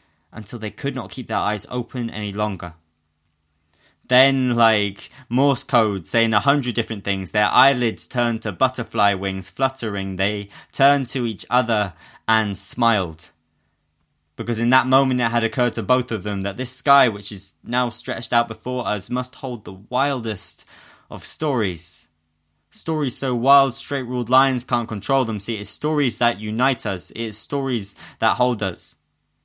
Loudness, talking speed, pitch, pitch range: -21 LUFS, 165 wpm, 115 Hz, 100-130 Hz